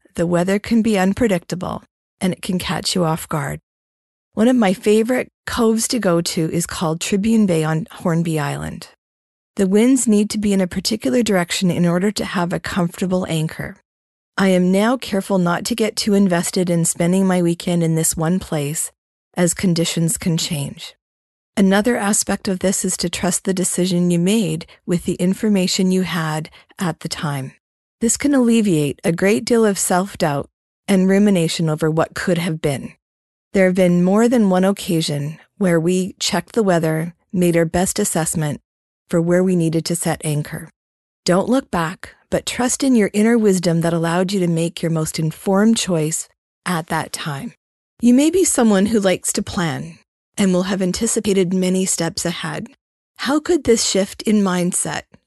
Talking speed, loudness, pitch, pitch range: 180 wpm, -18 LUFS, 180 Hz, 165-205 Hz